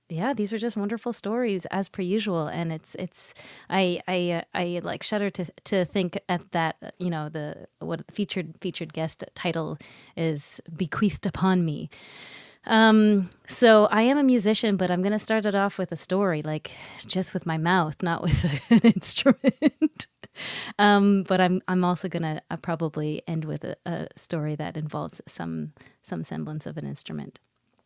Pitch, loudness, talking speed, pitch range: 185 Hz, -25 LUFS, 170 wpm, 165-205 Hz